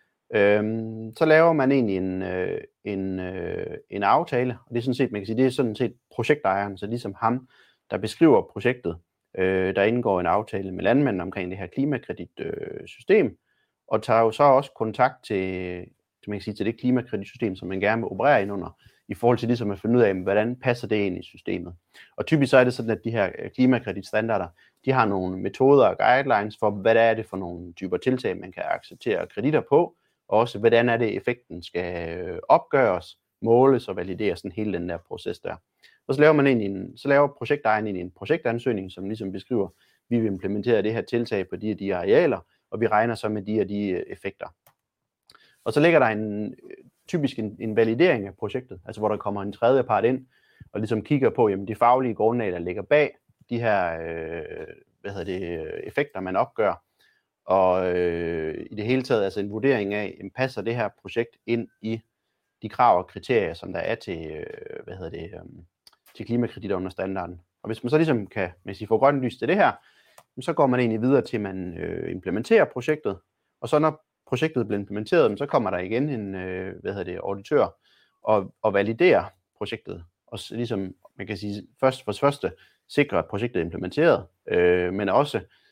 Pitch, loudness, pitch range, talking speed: 110 Hz, -24 LUFS, 95-125 Hz, 200 wpm